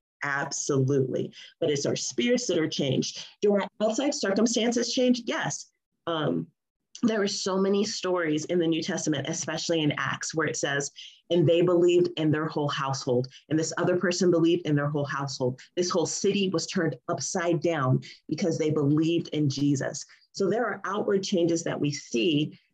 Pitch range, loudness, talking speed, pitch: 150-190 Hz, -27 LUFS, 175 wpm, 170 Hz